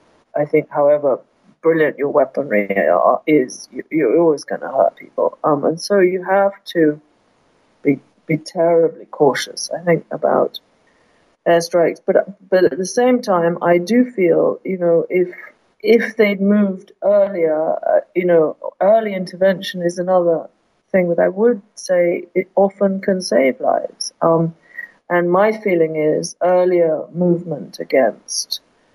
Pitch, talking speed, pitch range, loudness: 180 Hz, 145 wpm, 165-200 Hz, -17 LUFS